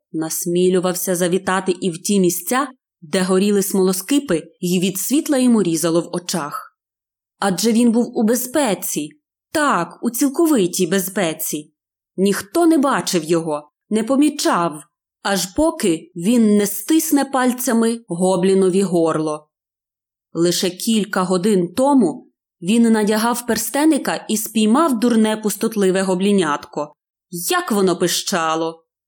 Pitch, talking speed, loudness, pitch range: 190 Hz, 110 wpm, -18 LUFS, 175-235 Hz